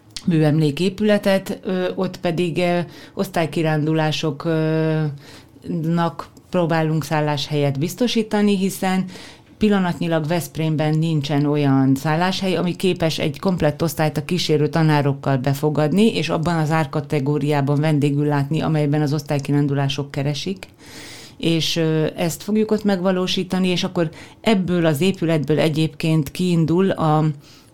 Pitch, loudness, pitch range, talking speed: 160 Hz, -20 LUFS, 150-180 Hz, 100 wpm